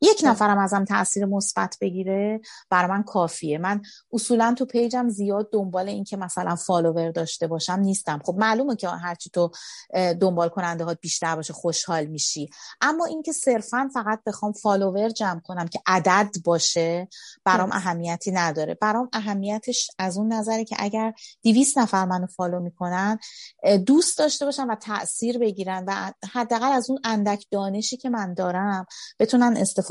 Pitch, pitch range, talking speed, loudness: 200 Hz, 180-225 Hz, 155 wpm, -24 LUFS